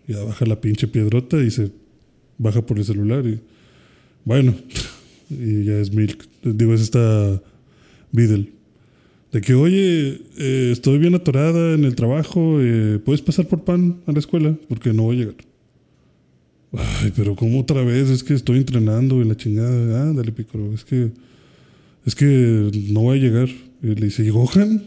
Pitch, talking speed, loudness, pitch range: 120 Hz, 175 wpm, -19 LUFS, 110-140 Hz